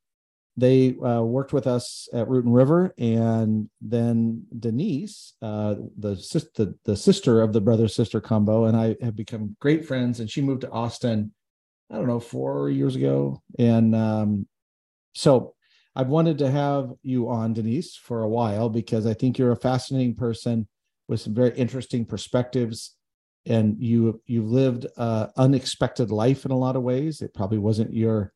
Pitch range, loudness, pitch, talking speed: 110-125 Hz, -24 LUFS, 115 Hz, 175 wpm